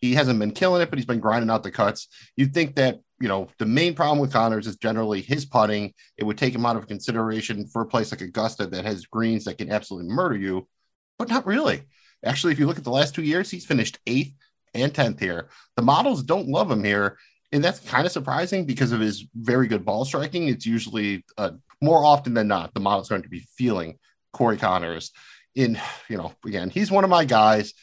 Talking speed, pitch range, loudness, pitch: 235 wpm, 105-135 Hz, -23 LUFS, 115 Hz